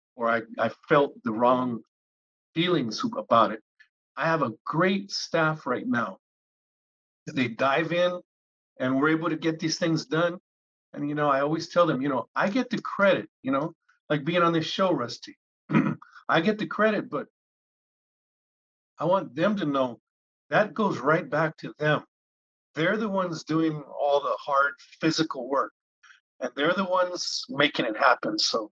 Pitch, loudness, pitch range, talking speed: 160 Hz, -26 LUFS, 135-175 Hz, 170 wpm